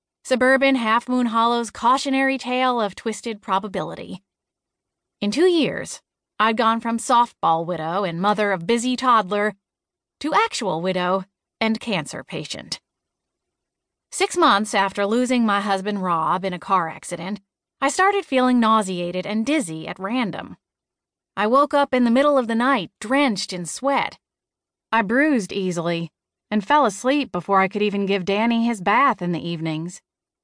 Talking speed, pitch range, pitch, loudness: 150 wpm, 190-255 Hz, 220 Hz, -21 LUFS